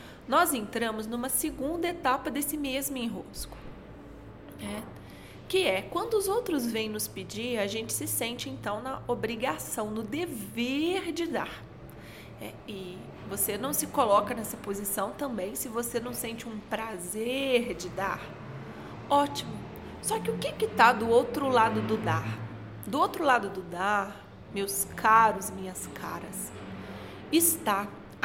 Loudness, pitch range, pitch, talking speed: -29 LUFS, 215-285 Hz, 235 Hz, 140 wpm